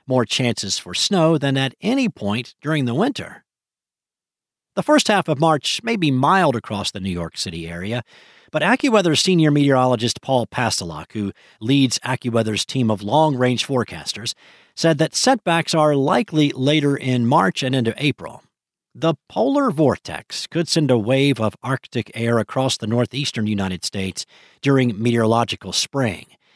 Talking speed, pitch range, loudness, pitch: 155 wpm, 110-155 Hz, -19 LUFS, 130 Hz